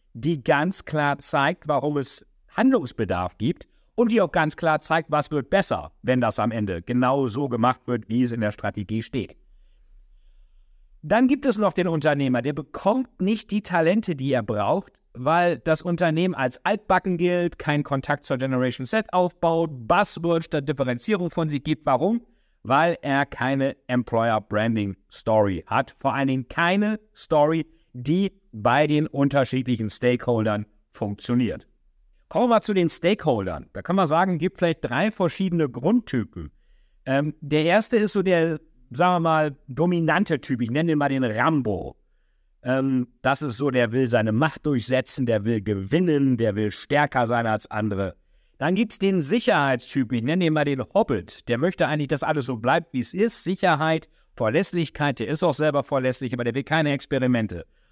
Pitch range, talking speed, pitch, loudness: 125-170 Hz, 170 wpm, 145 Hz, -23 LUFS